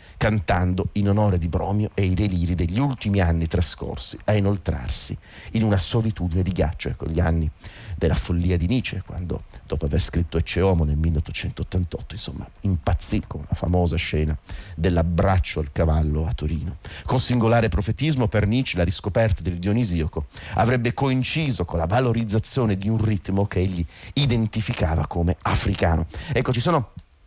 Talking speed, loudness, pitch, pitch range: 150 wpm, -23 LUFS, 95 Hz, 85-105 Hz